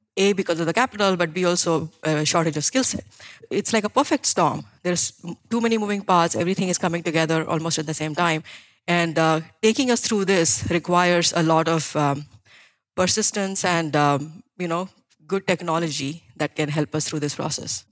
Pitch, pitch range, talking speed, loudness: 170 Hz, 155-190 Hz, 190 wpm, -21 LUFS